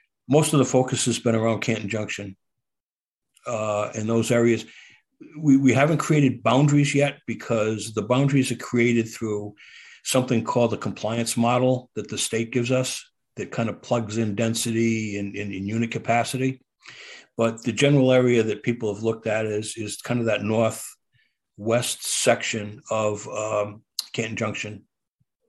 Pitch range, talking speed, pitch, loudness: 110-125 Hz, 160 wpm, 115 Hz, -23 LUFS